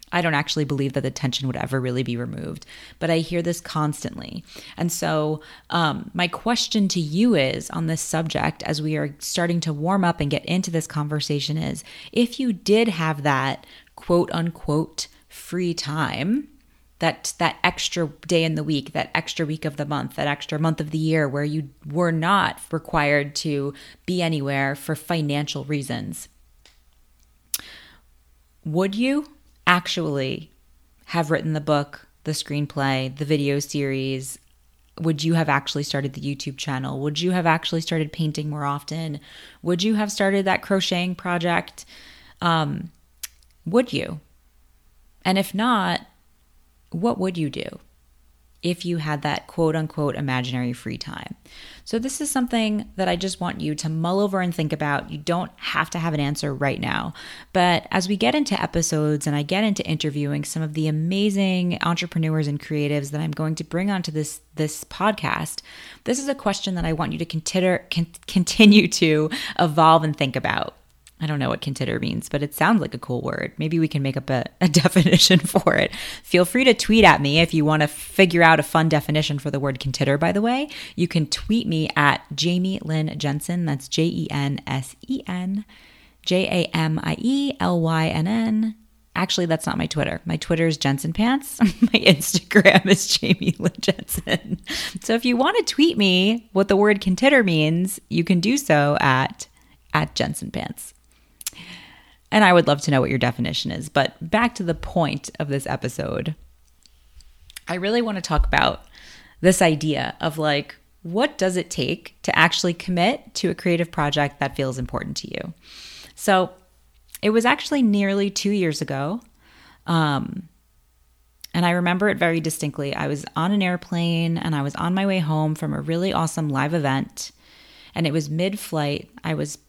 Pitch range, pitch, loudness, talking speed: 145-185 Hz, 160 Hz, -22 LUFS, 180 wpm